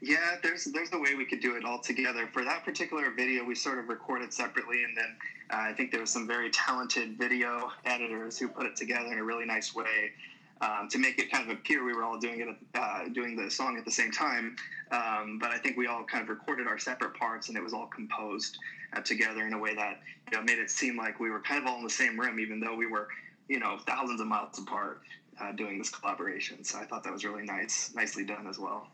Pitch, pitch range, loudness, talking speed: 115 Hz, 110-125 Hz, -32 LUFS, 260 wpm